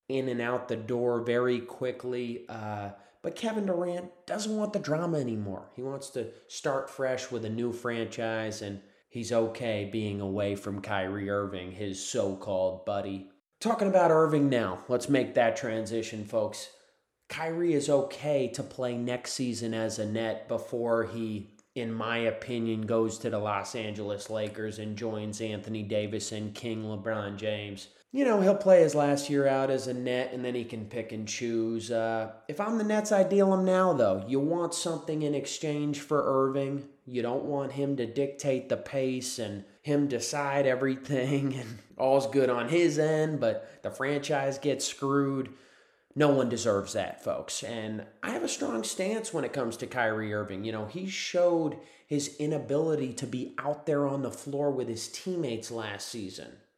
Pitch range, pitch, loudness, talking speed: 110-145 Hz, 125 Hz, -30 LUFS, 180 wpm